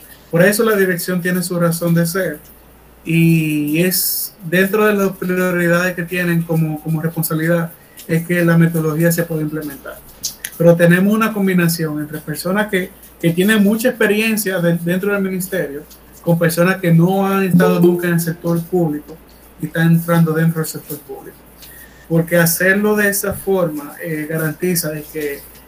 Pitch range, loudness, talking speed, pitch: 160-185 Hz, -16 LUFS, 160 wpm, 170 Hz